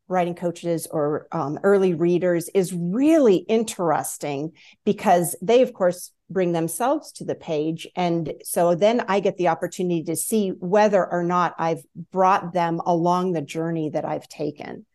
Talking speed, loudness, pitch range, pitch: 155 wpm, -22 LUFS, 165-195 Hz, 175 Hz